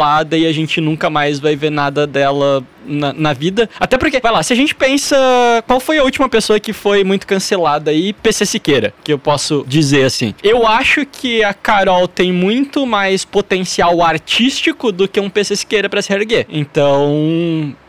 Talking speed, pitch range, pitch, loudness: 190 wpm, 150-225 Hz, 195 Hz, -13 LUFS